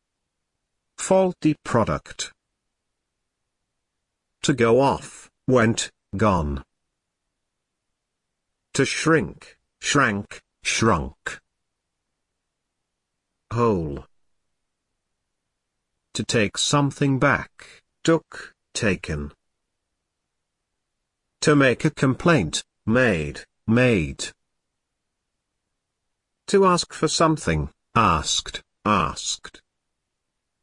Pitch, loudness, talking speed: 120 Hz, -22 LUFS, 60 wpm